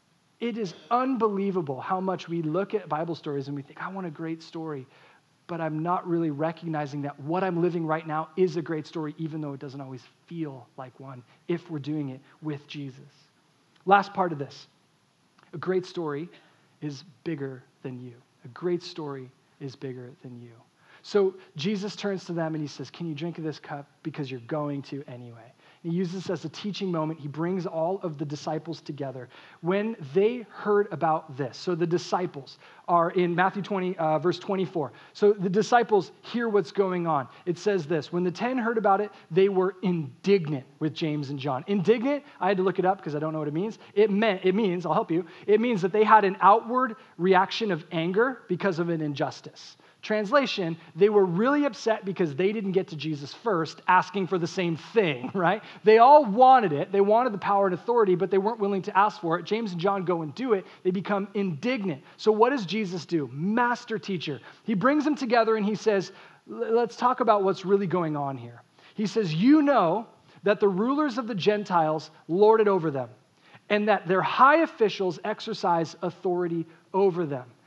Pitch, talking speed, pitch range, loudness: 180 Hz, 200 wpm, 155-205 Hz, -26 LUFS